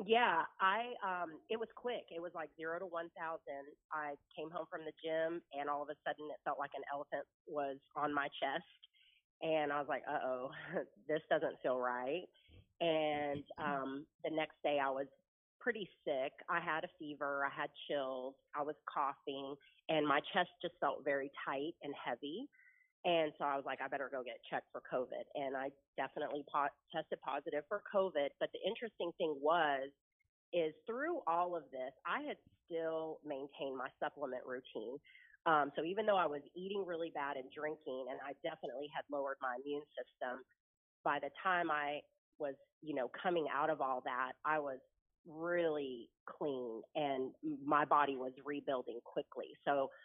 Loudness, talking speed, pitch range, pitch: -40 LUFS, 175 wpm, 140-165 Hz, 150 Hz